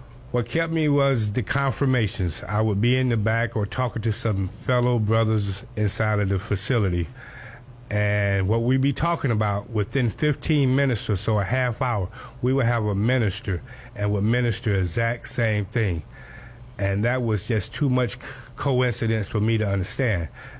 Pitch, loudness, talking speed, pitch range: 115 Hz, -24 LUFS, 170 wpm, 105-125 Hz